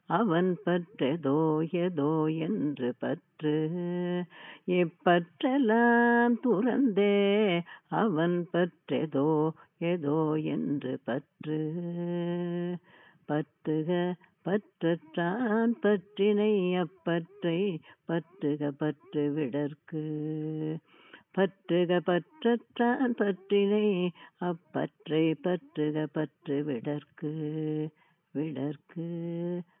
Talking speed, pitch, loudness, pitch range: 55 wpm, 170 Hz, -30 LUFS, 155-185 Hz